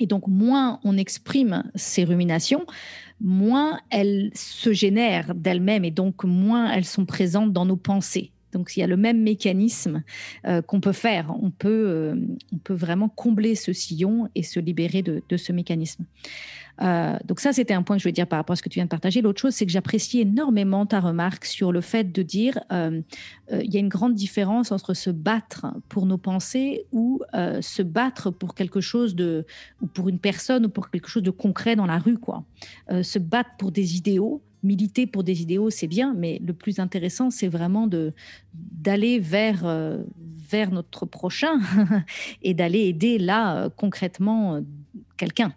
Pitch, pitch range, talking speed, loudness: 195 Hz, 180-220 Hz, 195 wpm, -23 LUFS